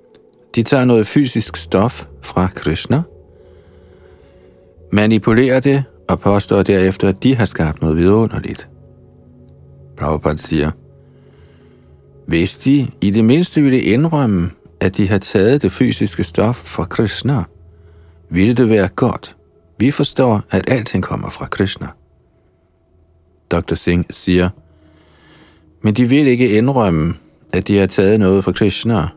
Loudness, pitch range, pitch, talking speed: -15 LUFS, 85-115 Hz, 95 Hz, 130 wpm